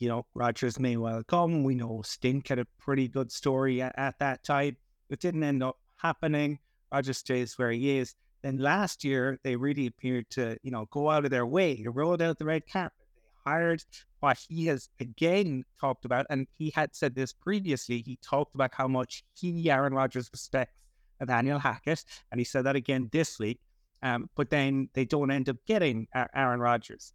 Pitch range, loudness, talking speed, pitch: 125-150 Hz, -30 LUFS, 200 wpm, 135 Hz